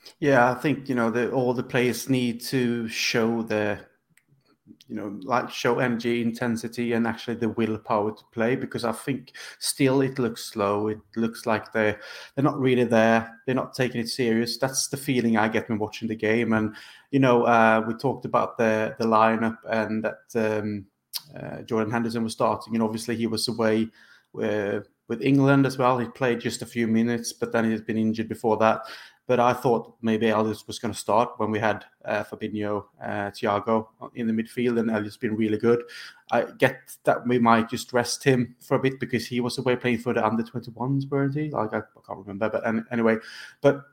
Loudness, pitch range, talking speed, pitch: -25 LUFS, 110-125 Hz, 205 wpm, 115 Hz